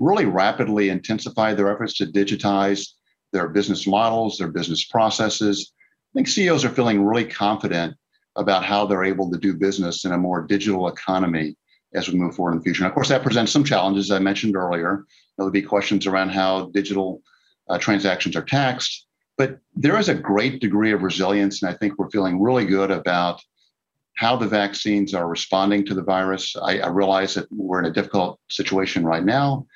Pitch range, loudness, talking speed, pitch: 95-105 Hz, -21 LUFS, 195 wpm, 100 Hz